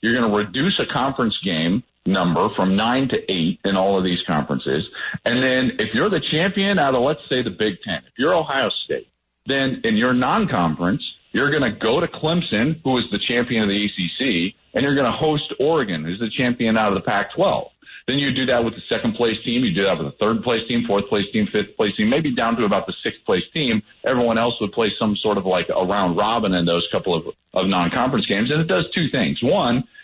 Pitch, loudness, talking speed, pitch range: 120 Hz, -20 LUFS, 230 wpm, 100-135 Hz